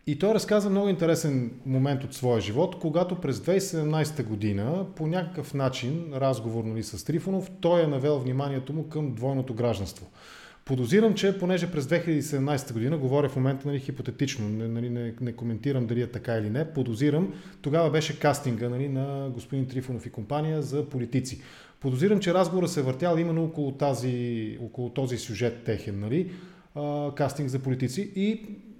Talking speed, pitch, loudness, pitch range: 160 wpm, 140 Hz, -28 LUFS, 125-165 Hz